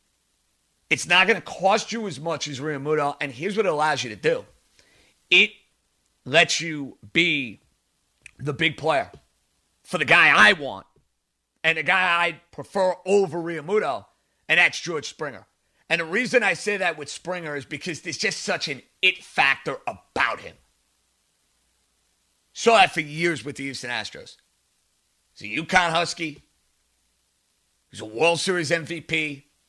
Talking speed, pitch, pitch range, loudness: 155 wpm, 160 Hz, 125-175 Hz, -22 LUFS